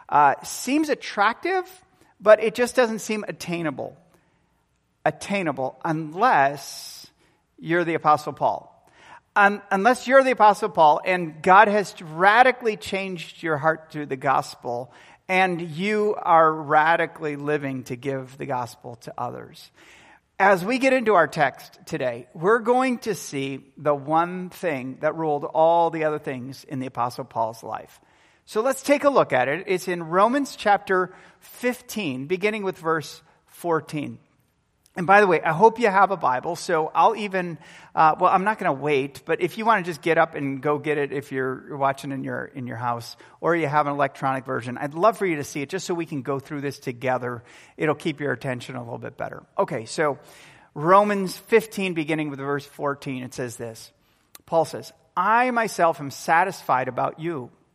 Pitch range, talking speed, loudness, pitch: 140-200 Hz, 180 wpm, -22 LUFS, 160 Hz